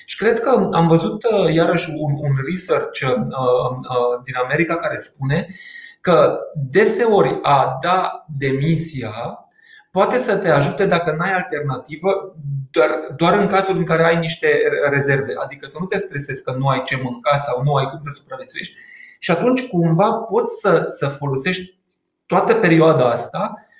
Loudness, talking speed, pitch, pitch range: -18 LUFS, 155 wpm, 165 Hz, 140-200 Hz